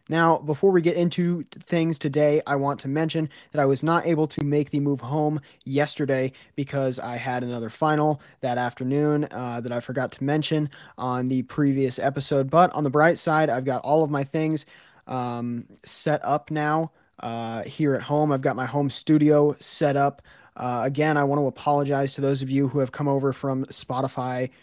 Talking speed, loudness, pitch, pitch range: 200 wpm, -24 LUFS, 140 Hz, 130-150 Hz